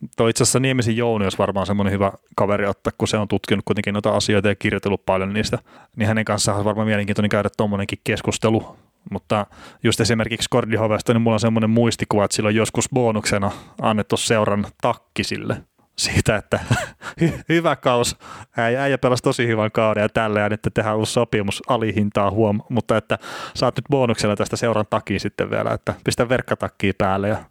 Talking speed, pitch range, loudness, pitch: 175 wpm, 105-120 Hz, -20 LUFS, 110 Hz